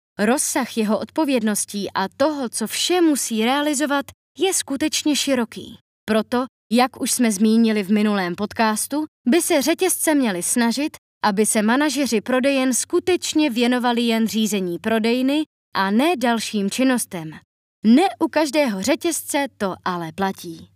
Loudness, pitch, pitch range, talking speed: -20 LUFS, 245 Hz, 215-295 Hz, 130 wpm